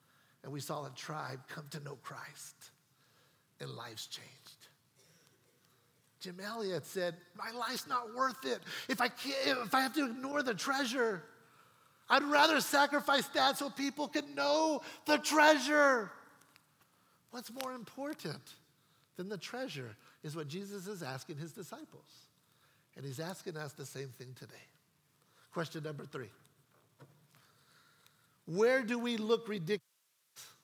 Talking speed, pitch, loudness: 135 wpm, 170 Hz, -34 LUFS